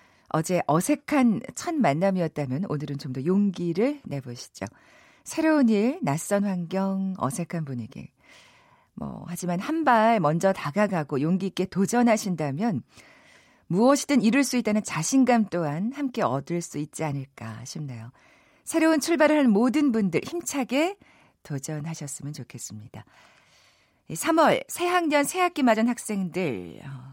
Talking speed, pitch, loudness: 275 characters per minute, 195 Hz, -25 LUFS